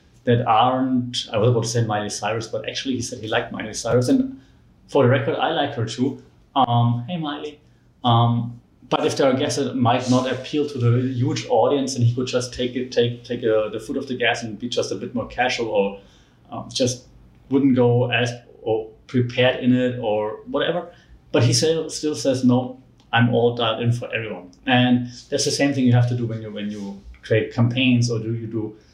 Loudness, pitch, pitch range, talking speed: -21 LUFS, 120 Hz, 115-130 Hz, 220 wpm